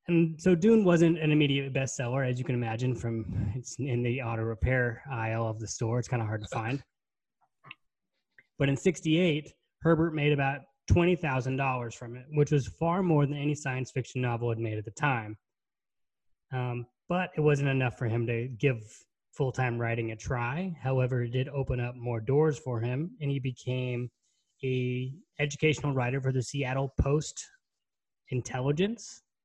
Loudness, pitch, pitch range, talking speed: -30 LUFS, 130 Hz, 120-145 Hz, 170 wpm